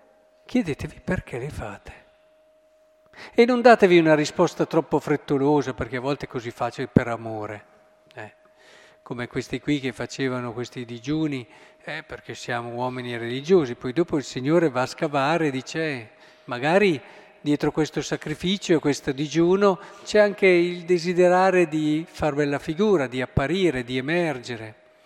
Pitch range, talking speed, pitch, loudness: 130-180 Hz, 145 wpm, 150 Hz, -23 LUFS